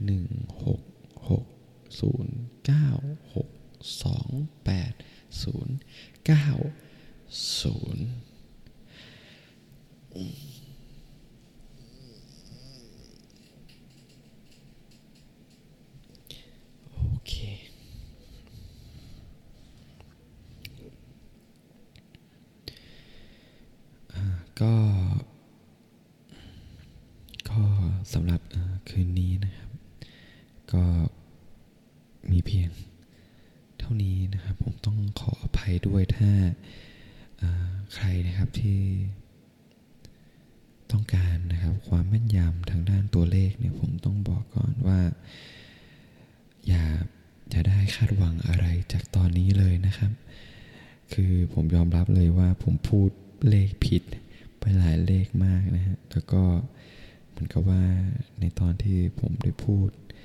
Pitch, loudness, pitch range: 100 Hz, -26 LUFS, 90-120 Hz